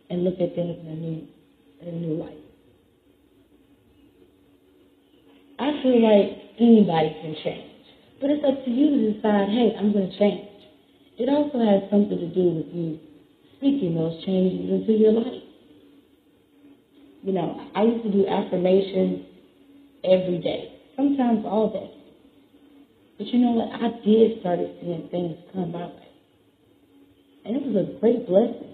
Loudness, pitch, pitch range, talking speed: -23 LUFS, 200 Hz, 175-235 Hz, 150 wpm